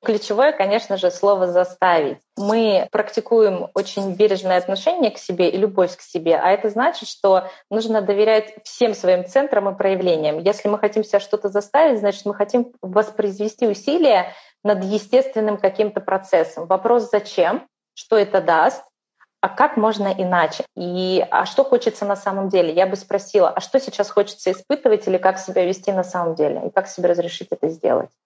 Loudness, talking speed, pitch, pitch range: -19 LUFS, 170 wpm, 200 Hz, 185-220 Hz